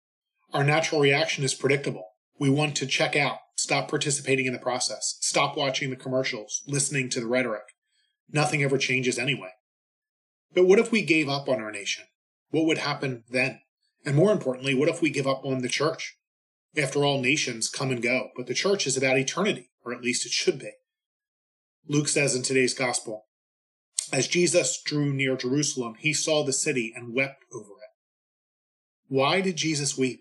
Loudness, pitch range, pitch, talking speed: -25 LUFS, 125-150 Hz, 135 Hz, 180 wpm